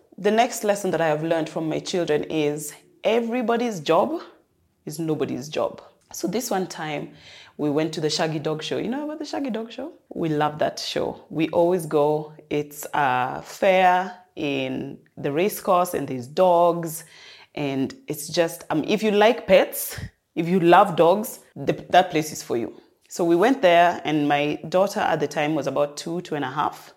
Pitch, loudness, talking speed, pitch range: 170 Hz, -23 LUFS, 195 wpm, 150-195 Hz